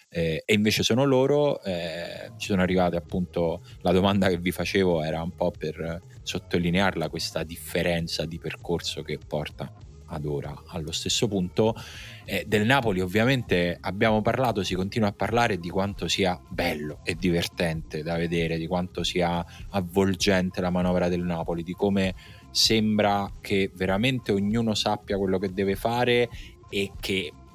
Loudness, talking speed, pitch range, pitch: -26 LUFS, 150 wpm, 85-105 Hz, 95 Hz